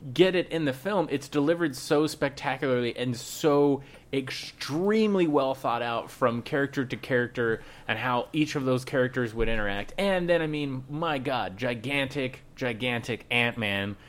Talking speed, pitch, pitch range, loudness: 160 wpm, 135 Hz, 120-150 Hz, -28 LUFS